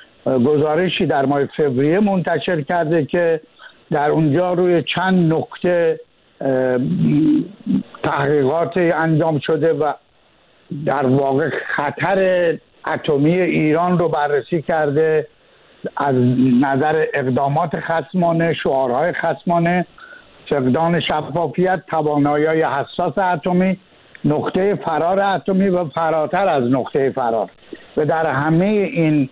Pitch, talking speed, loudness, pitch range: 160 Hz, 100 wpm, -18 LUFS, 145-180 Hz